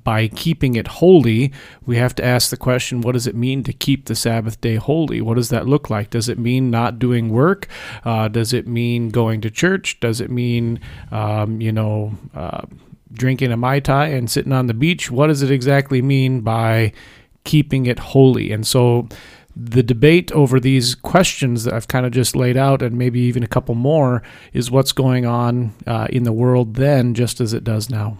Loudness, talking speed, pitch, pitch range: -17 LUFS, 205 wpm, 125 Hz, 115-135 Hz